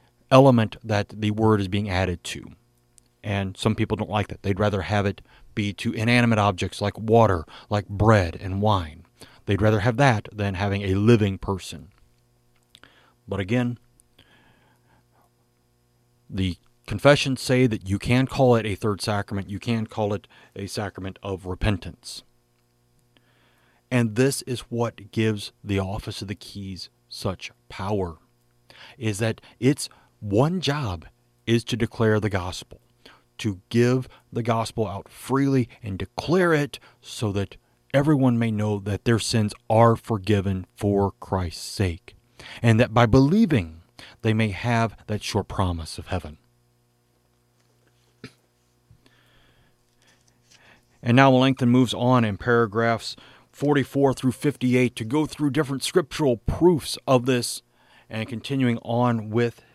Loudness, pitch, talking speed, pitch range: -23 LUFS, 110 Hz, 140 wpm, 95-120 Hz